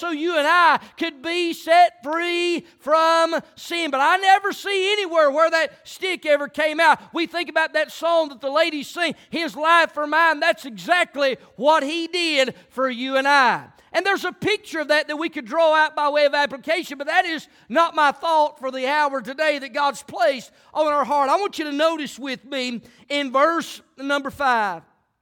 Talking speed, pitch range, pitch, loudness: 200 wpm, 285-330 Hz, 310 Hz, -20 LUFS